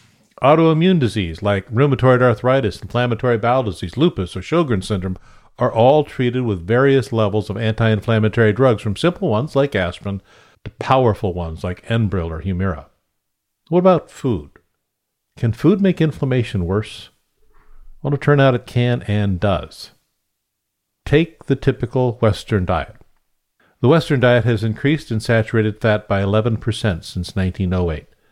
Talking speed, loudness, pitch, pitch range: 140 wpm, -18 LUFS, 110 Hz, 100-130 Hz